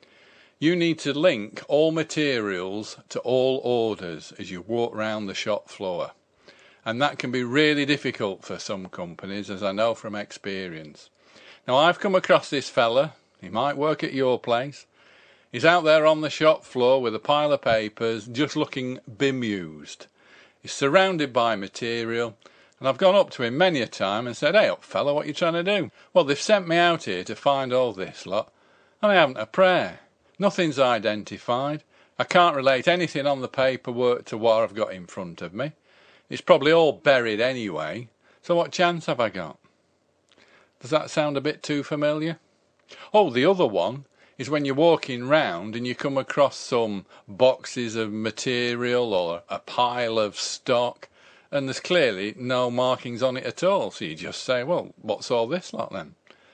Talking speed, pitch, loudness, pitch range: 185 wpm, 130 Hz, -24 LUFS, 115-150 Hz